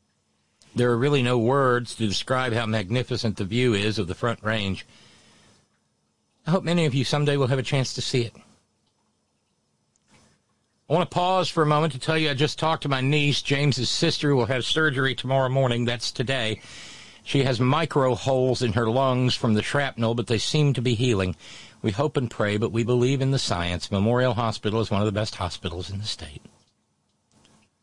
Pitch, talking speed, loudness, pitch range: 125 Hz, 200 wpm, -24 LUFS, 110-140 Hz